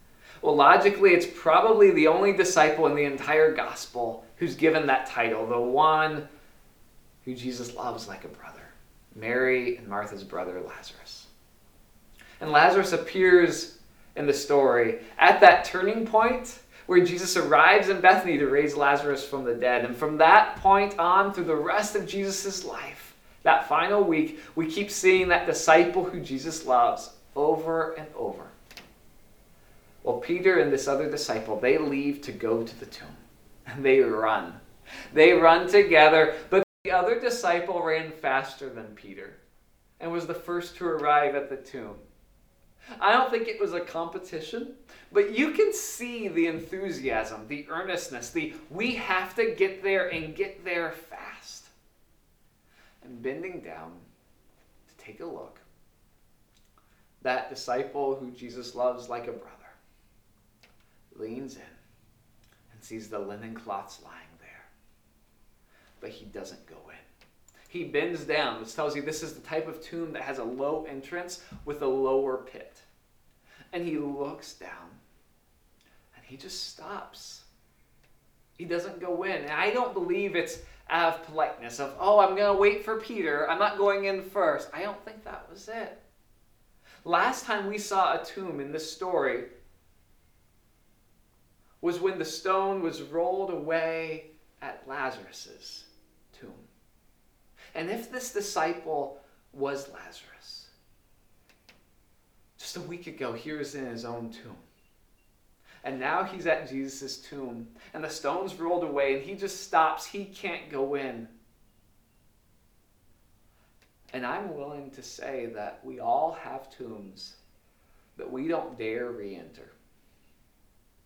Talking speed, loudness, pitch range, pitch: 145 wpm, -25 LUFS, 130-185 Hz, 155 Hz